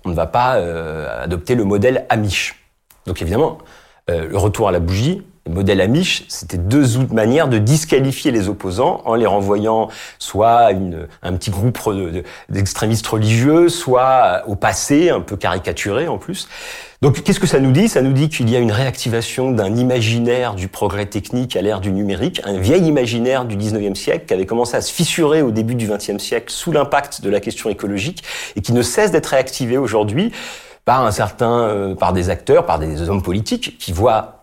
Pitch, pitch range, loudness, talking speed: 110 Hz, 100-130 Hz, -17 LUFS, 200 wpm